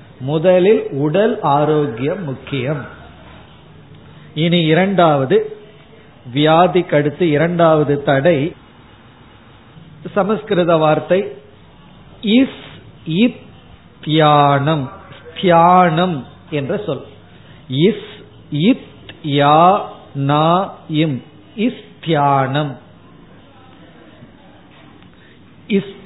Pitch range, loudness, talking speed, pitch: 135-180 Hz, -15 LUFS, 40 wpm, 155 Hz